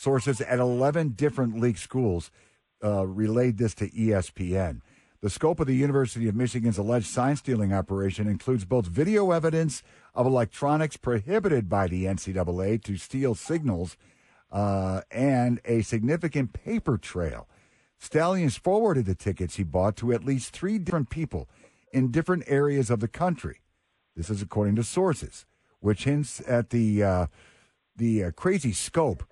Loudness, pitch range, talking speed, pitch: -27 LUFS, 100-140 Hz, 150 wpm, 120 Hz